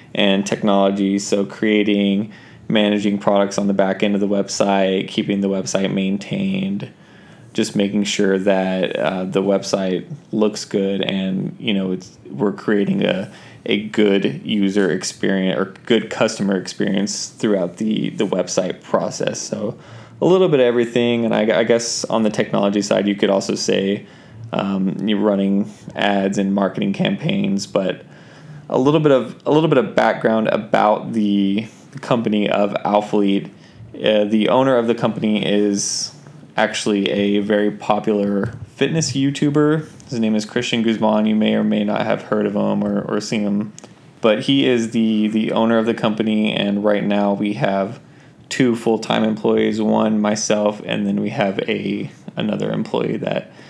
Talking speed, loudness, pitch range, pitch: 160 wpm, -19 LUFS, 100-115 Hz, 105 Hz